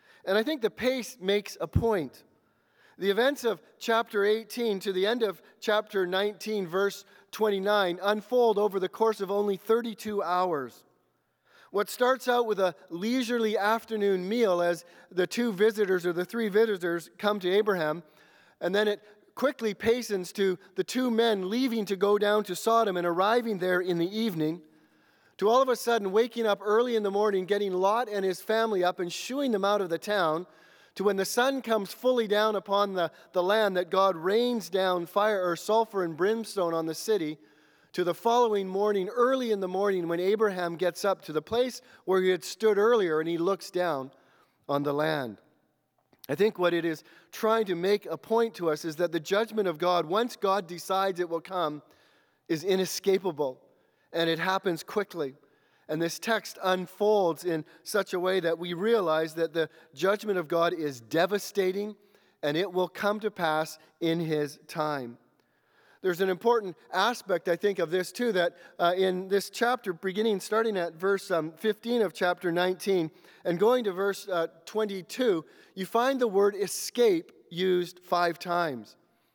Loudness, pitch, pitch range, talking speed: -28 LUFS, 195 Hz, 175-220 Hz, 180 wpm